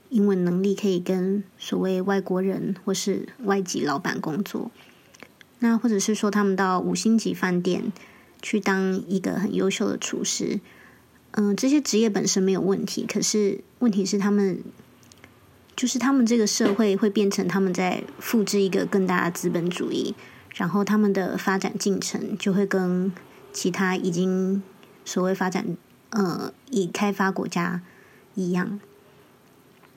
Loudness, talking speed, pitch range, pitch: -24 LUFS, 230 characters per minute, 185-210 Hz, 195 Hz